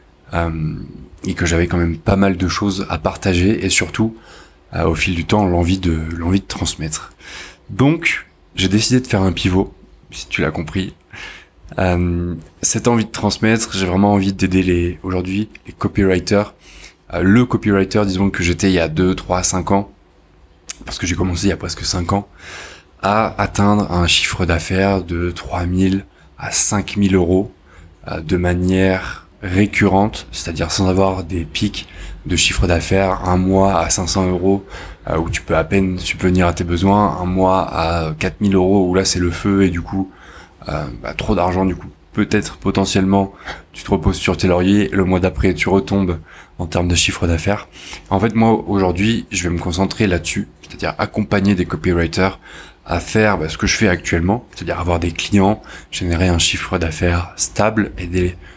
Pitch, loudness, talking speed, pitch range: 95 Hz, -17 LUFS, 180 wpm, 85-100 Hz